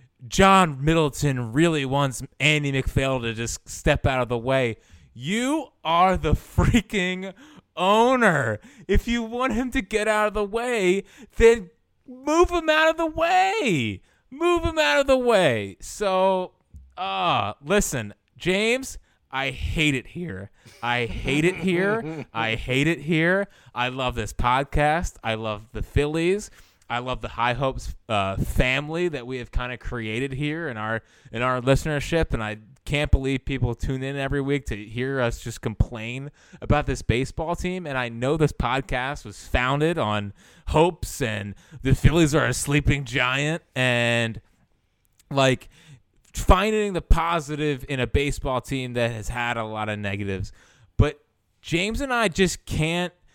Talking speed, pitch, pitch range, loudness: 155 wpm, 140 Hz, 120-180 Hz, -23 LUFS